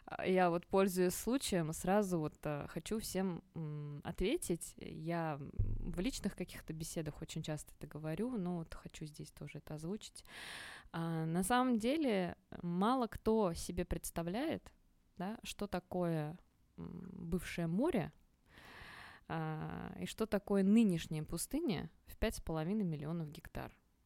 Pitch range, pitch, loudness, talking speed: 160-205 Hz, 180 Hz, -39 LUFS, 120 wpm